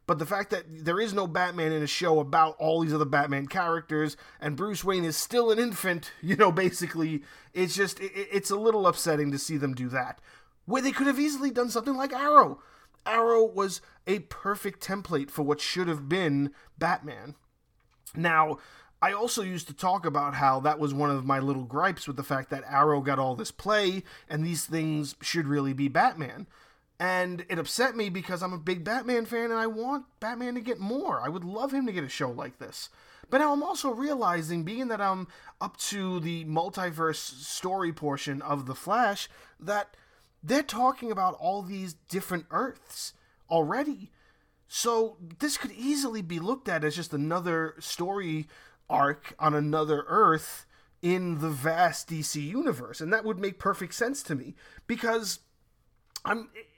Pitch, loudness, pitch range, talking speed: 180 Hz, -28 LUFS, 155-220 Hz, 180 wpm